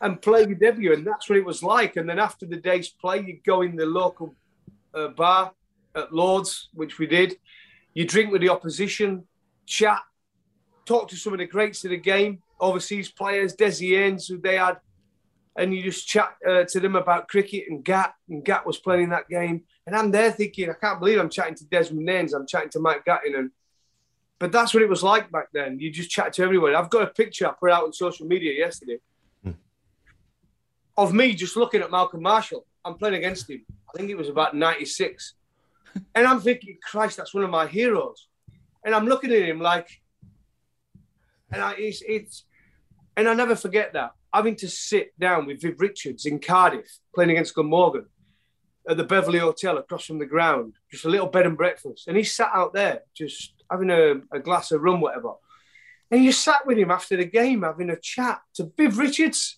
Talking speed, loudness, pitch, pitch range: 205 wpm, -23 LUFS, 185 Hz, 165-210 Hz